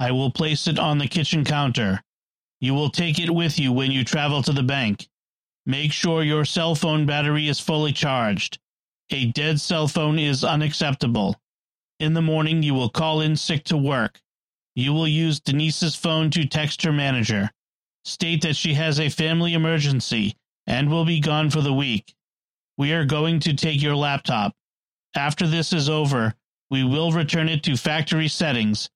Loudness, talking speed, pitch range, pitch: -22 LUFS, 180 wpm, 140-160 Hz, 150 Hz